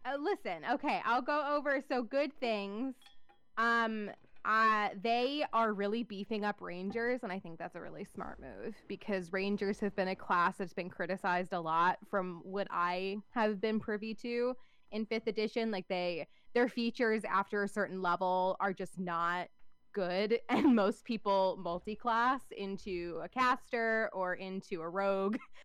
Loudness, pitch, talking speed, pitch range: -35 LUFS, 210 Hz, 160 wpm, 190-235 Hz